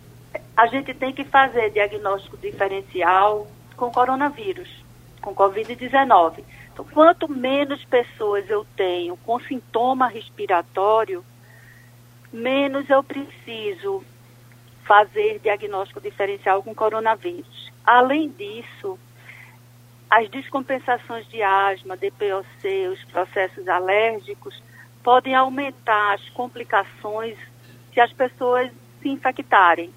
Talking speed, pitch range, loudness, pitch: 95 wpm, 185-265 Hz, -21 LUFS, 220 Hz